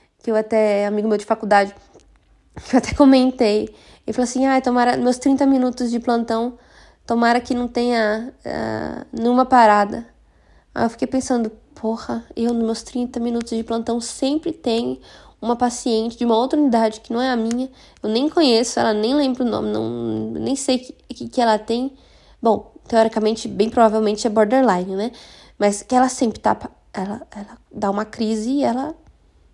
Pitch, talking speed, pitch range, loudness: 235 Hz, 185 wpm, 220-255 Hz, -19 LUFS